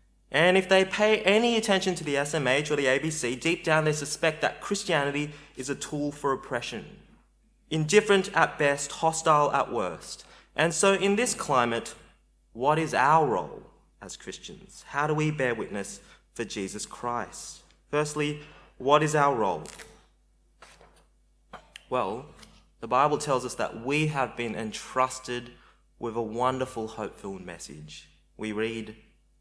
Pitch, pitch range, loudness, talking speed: 145 Hz, 115-160 Hz, -26 LUFS, 145 wpm